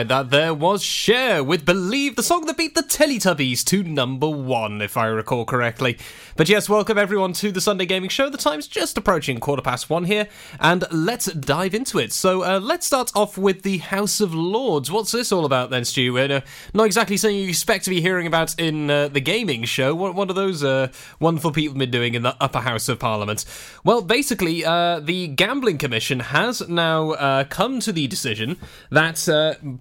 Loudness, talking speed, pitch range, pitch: -20 LUFS, 205 wpm, 140-205 Hz, 170 Hz